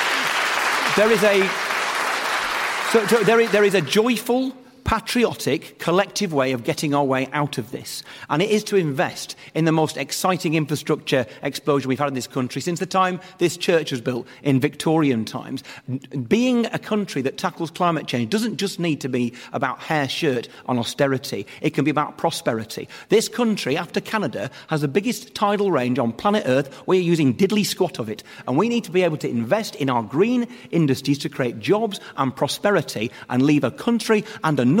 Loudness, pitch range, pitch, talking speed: -21 LUFS, 135-205 Hz, 160 Hz, 190 wpm